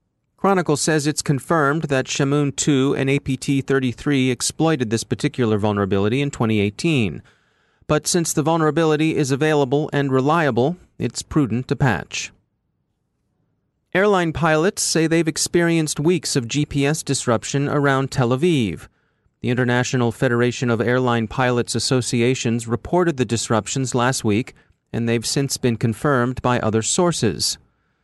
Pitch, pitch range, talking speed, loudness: 135 Hz, 120-155 Hz, 130 wpm, -20 LUFS